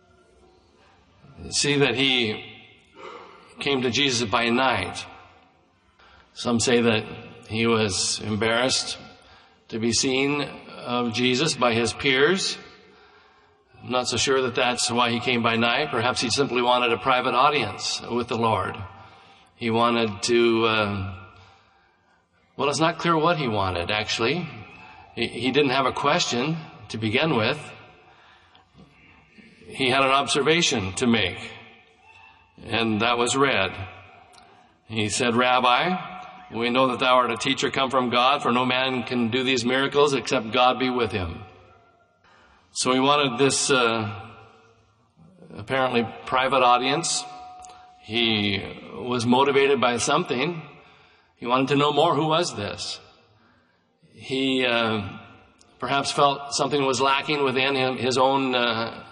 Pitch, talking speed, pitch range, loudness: 120 Hz, 135 wpm, 110-135 Hz, -22 LUFS